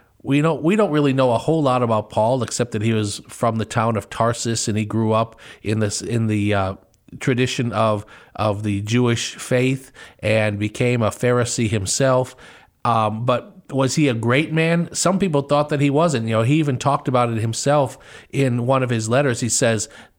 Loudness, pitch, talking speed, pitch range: -20 LUFS, 120 Hz, 200 wpm, 110-140 Hz